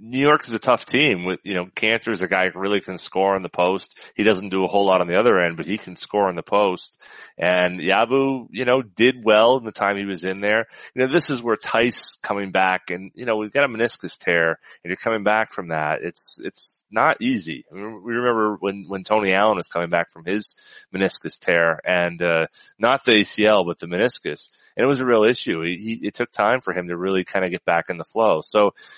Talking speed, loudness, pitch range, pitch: 255 wpm, -21 LUFS, 90-115 Hz, 100 Hz